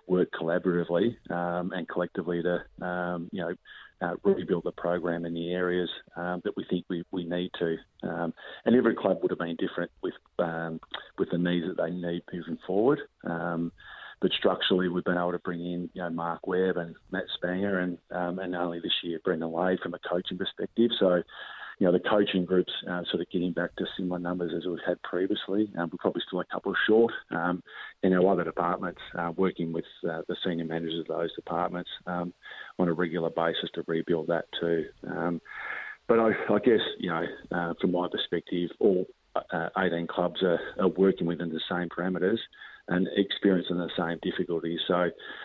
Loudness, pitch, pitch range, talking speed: -29 LUFS, 90 Hz, 85-90 Hz, 195 wpm